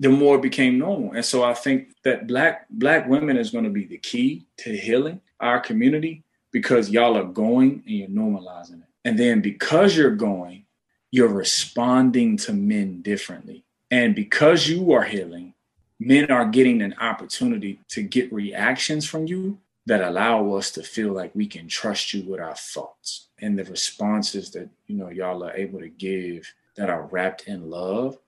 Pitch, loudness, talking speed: 125 Hz, -22 LUFS, 180 wpm